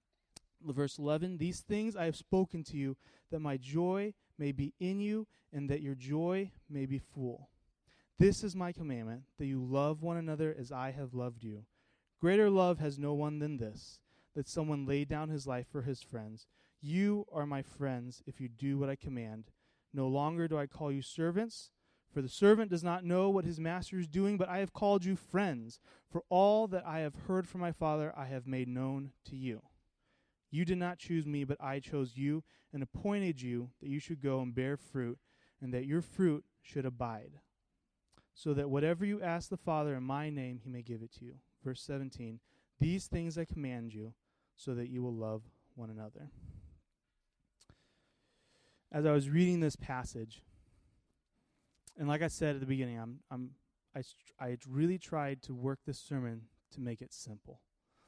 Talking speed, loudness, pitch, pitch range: 190 wpm, -37 LUFS, 140 Hz, 125-170 Hz